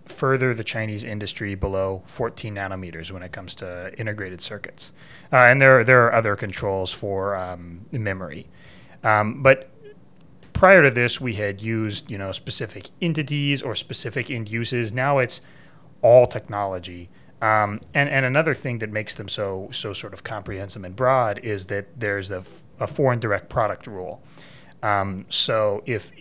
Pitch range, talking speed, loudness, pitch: 100-130 Hz, 165 wpm, -21 LUFS, 110 Hz